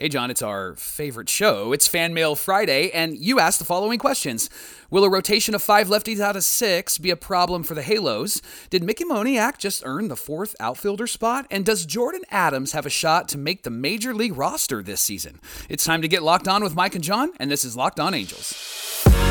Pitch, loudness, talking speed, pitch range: 180 Hz, -21 LUFS, 220 wpm, 150-210 Hz